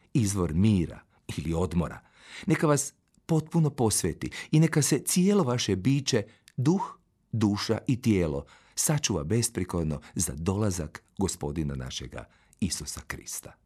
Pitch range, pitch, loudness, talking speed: 85-145 Hz, 110 Hz, -28 LUFS, 115 wpm